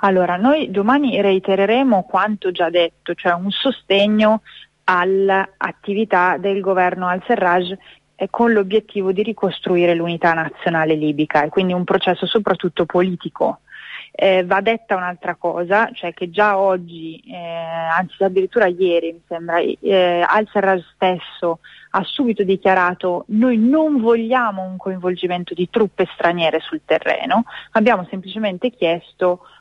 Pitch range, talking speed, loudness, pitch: 175-205 Hz, 125 wpm, -18 LUFS, 190 Hz